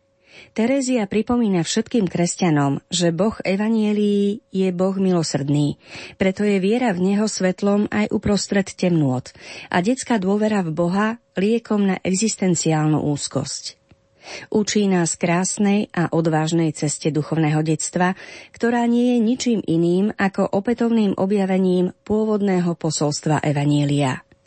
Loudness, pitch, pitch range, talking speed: -20 LUFS, 190 Hz, 165-215 Hz, 115 wpm